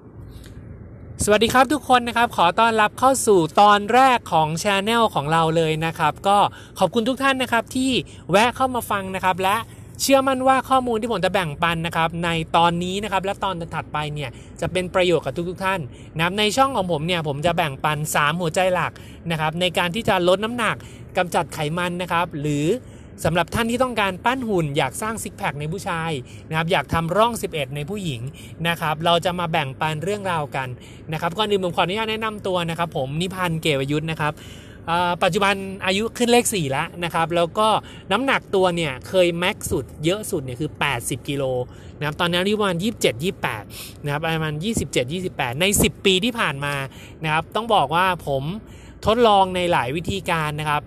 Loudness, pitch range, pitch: -21 LUFS, 155-205 Hz, 175 Hz